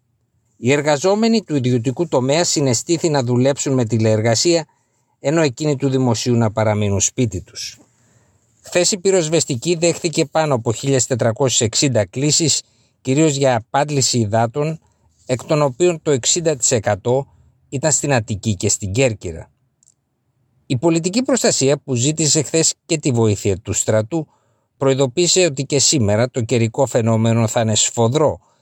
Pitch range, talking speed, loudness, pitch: 115-155 Hz, 130 wpm, -17 LUFS, 130 Hz